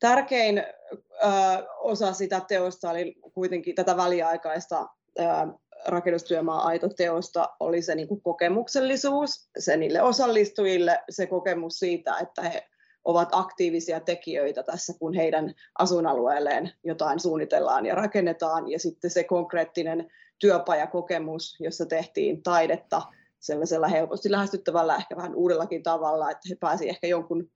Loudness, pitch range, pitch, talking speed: -26 LUFS, 165-190 Hz, 175 Hz, 120 wpm